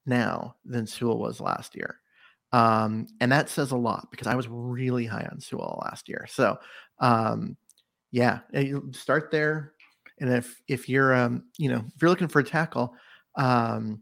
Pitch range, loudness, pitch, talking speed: 120-140 Hz, -27 LUFS, 125 Hz, 175 wpm